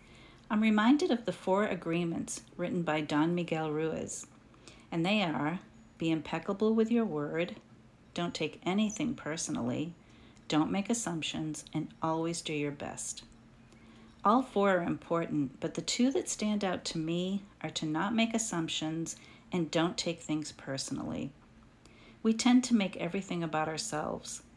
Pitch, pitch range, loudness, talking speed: 165 Hz, 155-200 Hz, -32 LUFS, 145 wpm